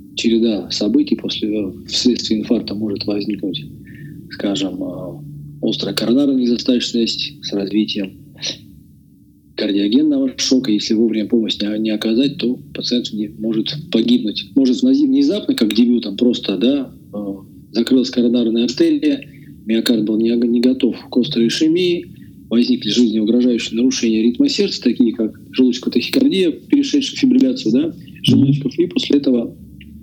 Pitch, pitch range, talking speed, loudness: 120 Hz, 110-155 Hz, 115 wpm, -17 LUFS